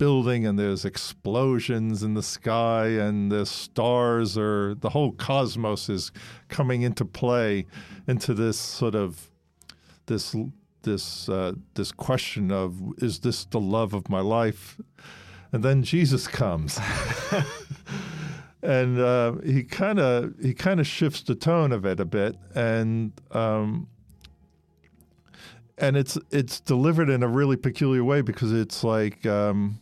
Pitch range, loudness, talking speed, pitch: 100-130 Hz, -25 LUFS, 140 wpm, 115 Hz